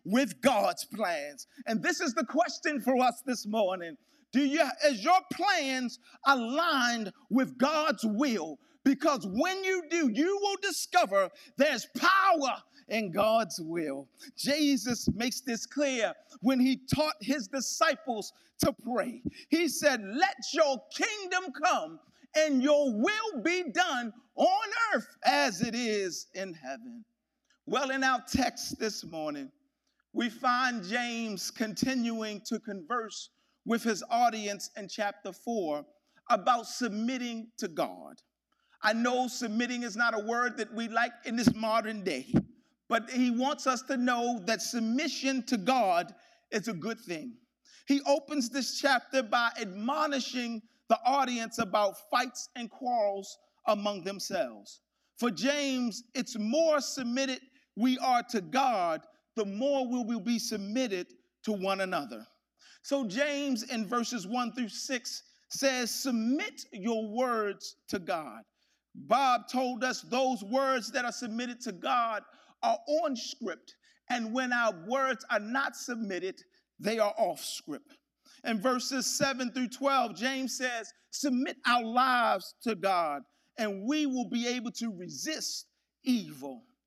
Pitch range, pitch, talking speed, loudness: 230-285 Hz, 250 Hz, 140 wpm, -30 LUFS